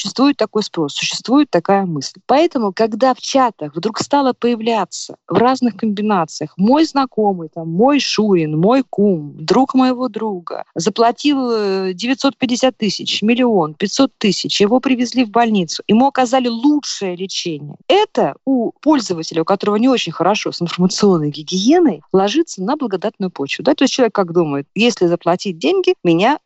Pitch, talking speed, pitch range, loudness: 215 Hz, 145 wpm, 180-255 Hz, -16 LUFS